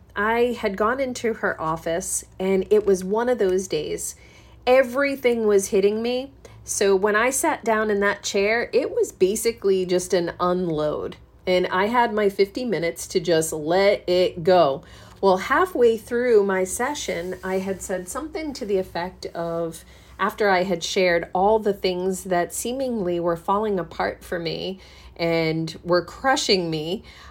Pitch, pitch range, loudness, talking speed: 195 Hz, 180-230 Hz, -22 LUFS, 160 wpm